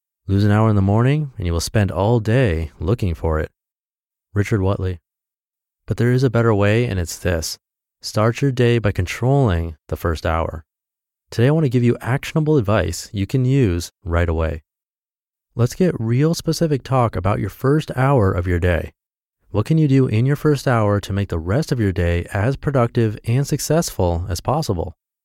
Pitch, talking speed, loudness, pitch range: 110 Hz, 190 wpm, -19 LUFS, 90-130 Hz